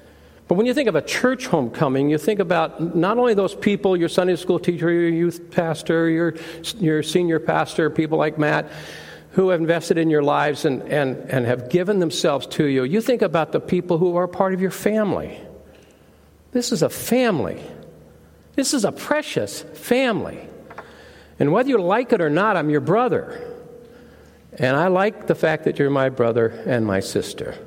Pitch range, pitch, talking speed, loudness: 155-200 Hz, 170 Hz, 185 wpm, -20 LUFS